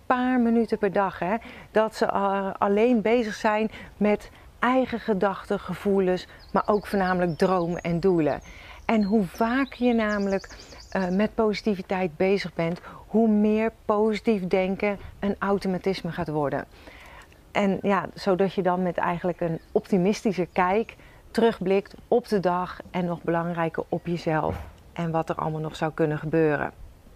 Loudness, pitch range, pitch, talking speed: -25 LUFS, 175-215 Hz, 195 Hz, 145 wpm